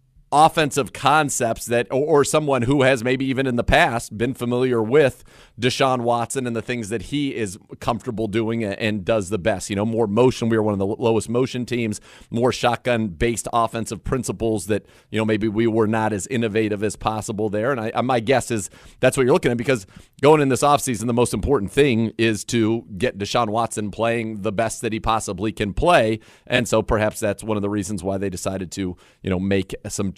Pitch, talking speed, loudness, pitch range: 115 Hz, 215 wpm, -21 LUFS, 110-125 Hz